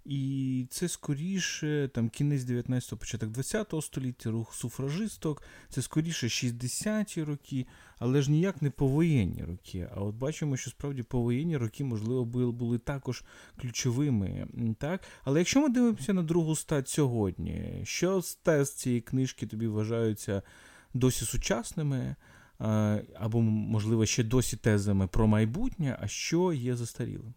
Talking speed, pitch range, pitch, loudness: 135 wpm, 115-150 Hz, 130 Hz, -31 LUFS